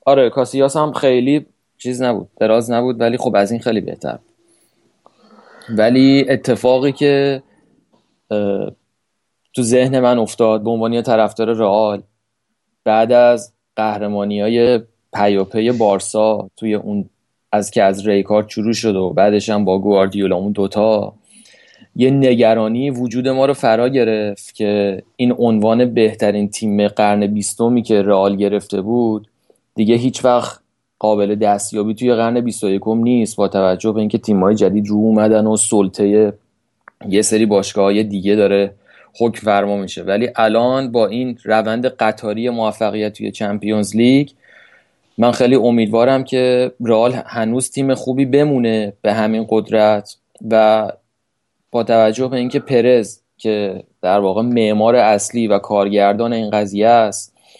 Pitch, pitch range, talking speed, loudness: 110 Hz, 105-120 Hz, 135 wpm, -15 LUFS